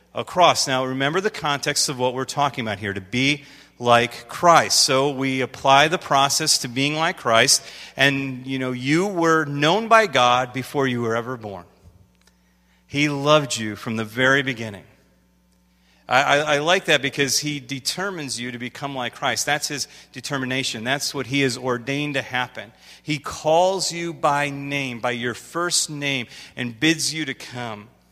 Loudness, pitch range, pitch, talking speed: -20 LUFS, 120-145 Hz, 135 Hz, 175 wpm